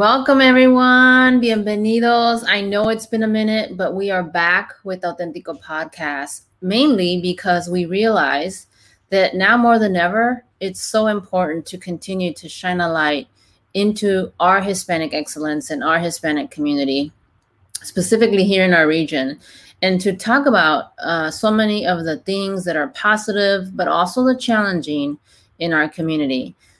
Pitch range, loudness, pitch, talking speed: 155-215 Hz, -17 LUFS, 185 Hz, 150 wpm